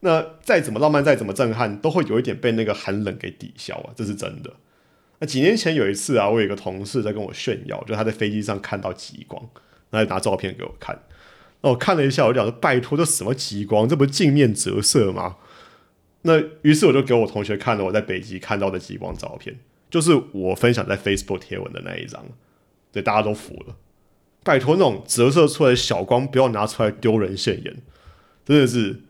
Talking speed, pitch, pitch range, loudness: 335 characters per minute, 110 Hz, 100-135 Hz, -20 LUFS